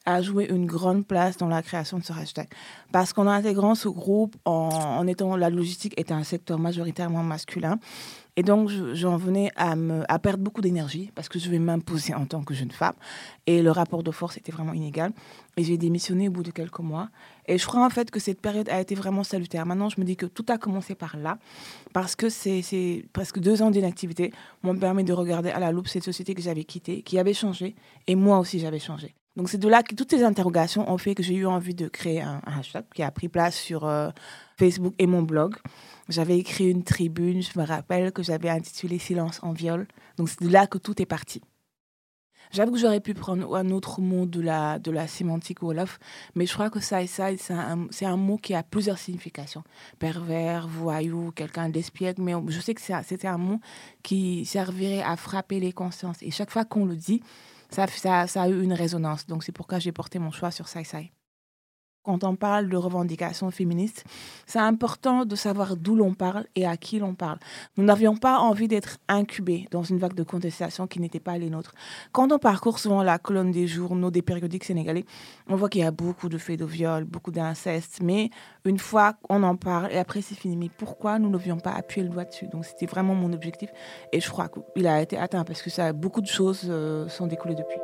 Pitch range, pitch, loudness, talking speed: 170-195 Hz, 180 Hz, -26 LUFS, 225 wpm